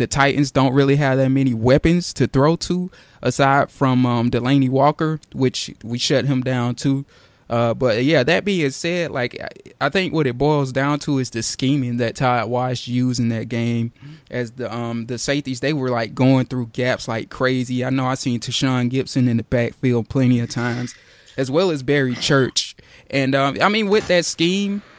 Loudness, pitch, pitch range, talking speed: -19 LUFS, 130 Hz, 125-145 Hz, 200 wpm